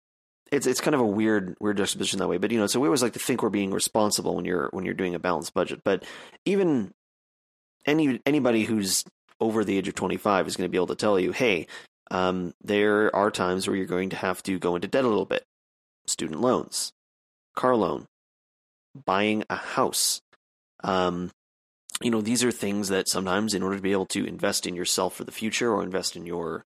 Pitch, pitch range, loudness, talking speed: 95 Hz, 90-110 Hz, -26 LUFS, 215 wpm